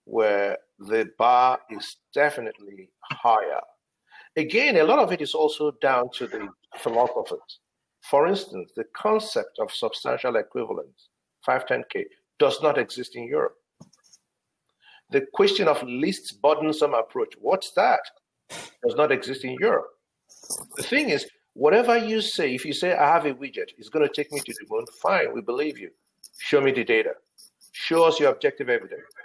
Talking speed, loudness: 160 wpm, -24 LUFS